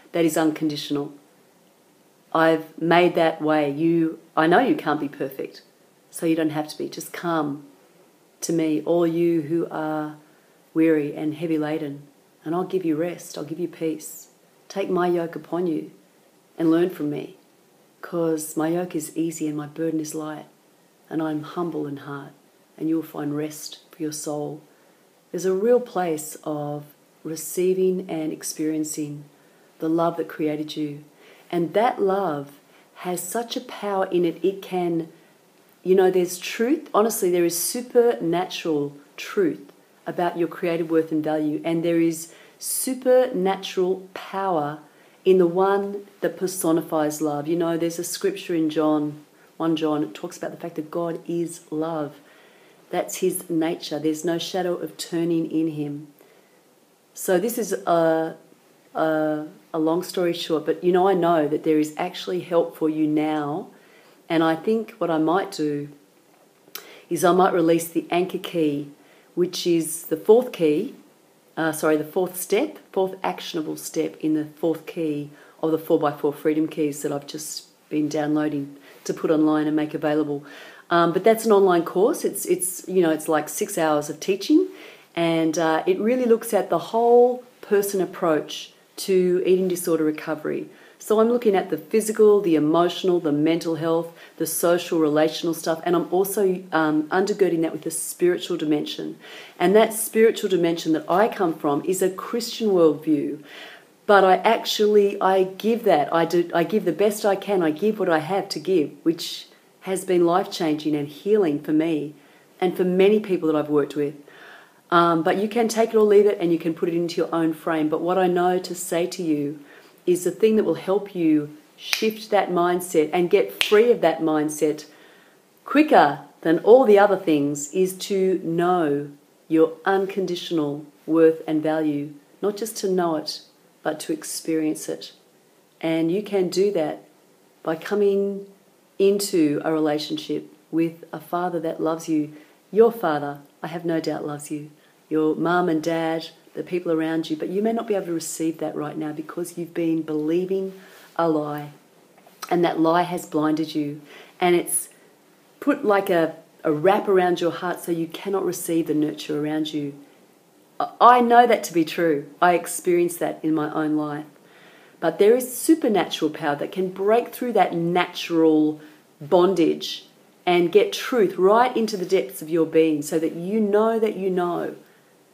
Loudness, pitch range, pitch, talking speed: -22 LUFS, 155-185 Hz, 165 Hz, 175 wpm